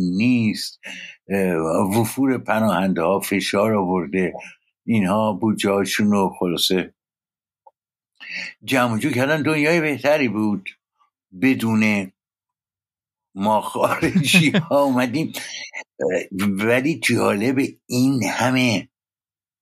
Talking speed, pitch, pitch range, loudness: 75 wpm, 110 Hz, 100-130 Hz, -20 LUFS